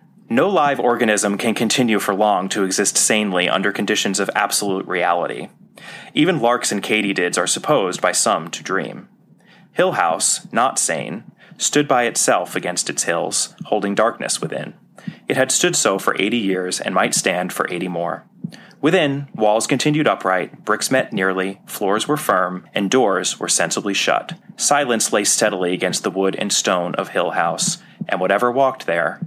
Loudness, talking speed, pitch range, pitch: -18 LUFS, 165 wpm, 95-120 Hz, 105 Hz